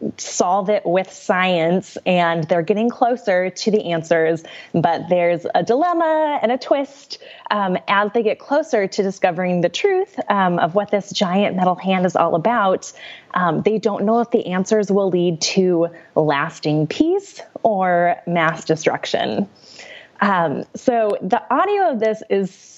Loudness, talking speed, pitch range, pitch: -19 LUFS, 160 wpm, 175-235 Hz, 195 Hz